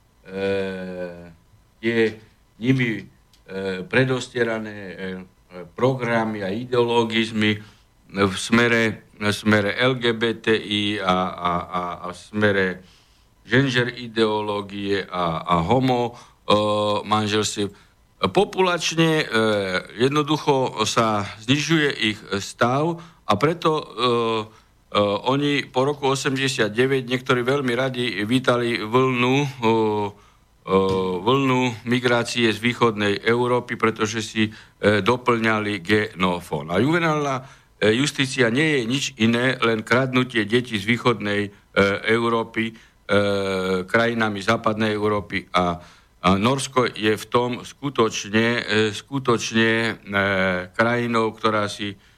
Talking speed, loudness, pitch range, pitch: 100 wpm, -21 LUFS, 100-125 Hz, 110 Hz